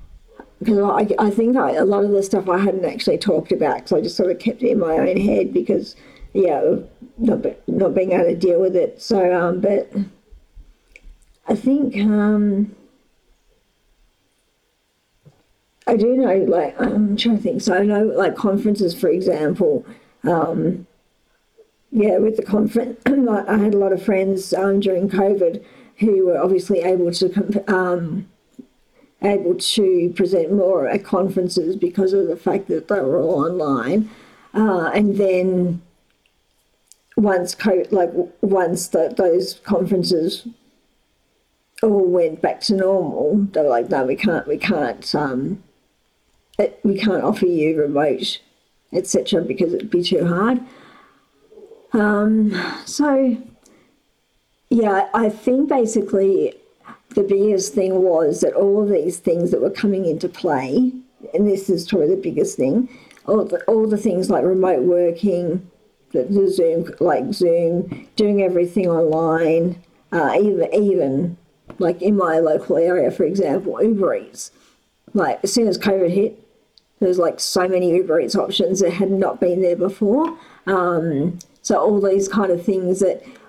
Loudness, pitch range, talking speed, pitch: -19 LUFS, 180-215 Hz, 150 wpm, 195 Hz